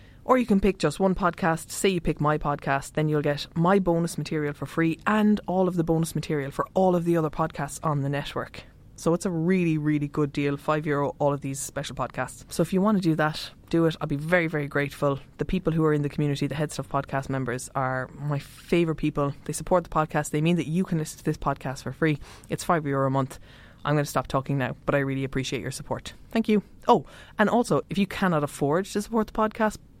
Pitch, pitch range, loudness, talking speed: 150 Hz, 140-175 Hz, -26 LUFS, 250 wpm